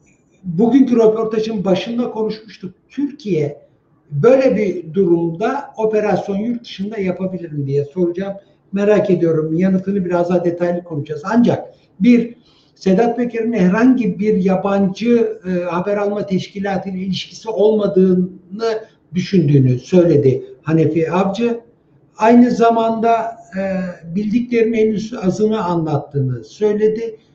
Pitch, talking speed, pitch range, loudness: 195 Hz, 105 wpm, 175-220 Hz, -16 LUFS